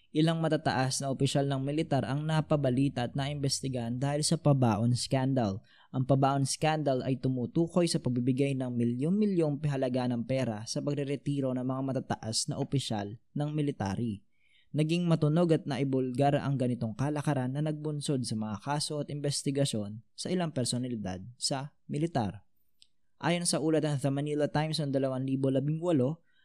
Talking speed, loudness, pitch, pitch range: 145 wpm, -31 LUFS, 140 Hz, 125-150 Hz